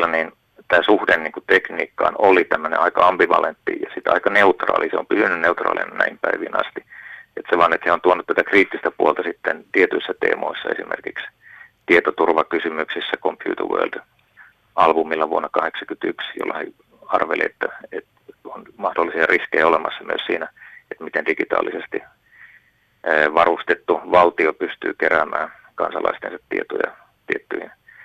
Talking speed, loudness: 130 wpm, -19 LUFS